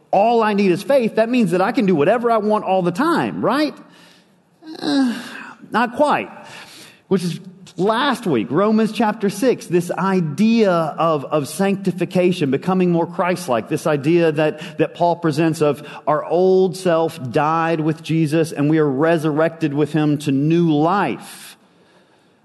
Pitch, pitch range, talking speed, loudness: 175 Hz, 160-215 Hz, 160 wpm, -18 LUFS